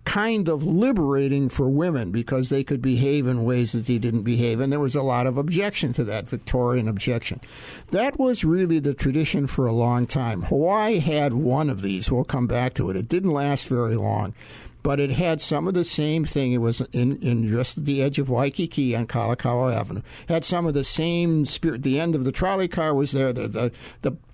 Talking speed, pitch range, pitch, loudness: 220 wpm, 120-155 Hz, 135 Hz, -23 LUFS